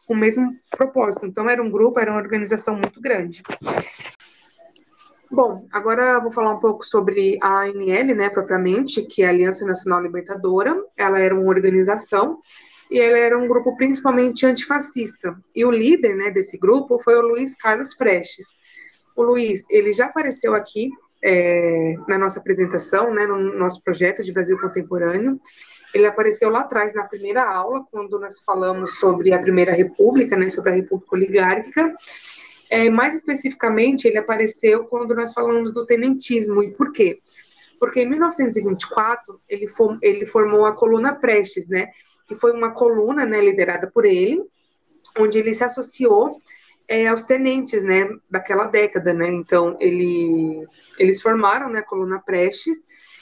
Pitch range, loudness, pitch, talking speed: 195-260 Hz, -19 LUFS, 225 Hz, 155 wpm